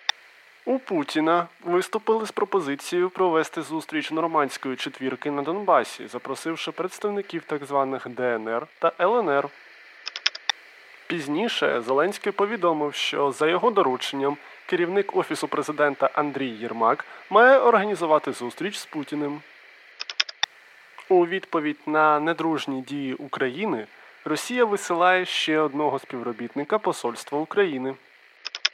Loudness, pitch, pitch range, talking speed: -24 LUFS, 155 Hz, 140-185 Hz, 100 wpm